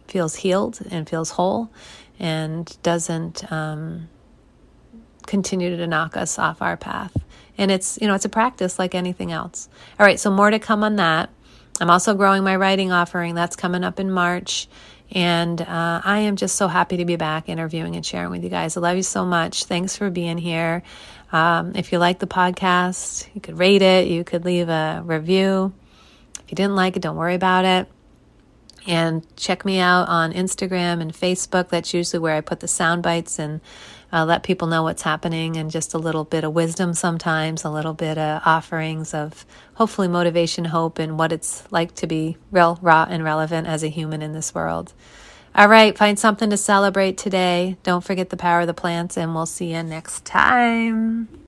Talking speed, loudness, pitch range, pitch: 195 wpm, -20 LUFS, 165-190 Hz, 175 Hz